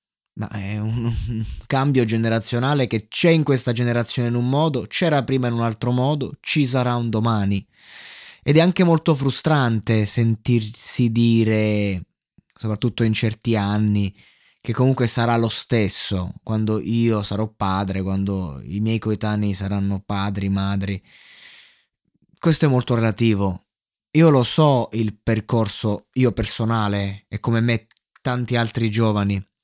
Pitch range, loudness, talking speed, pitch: 105-125 Hz, -20 LUFS, 140 wpm, 115 Hz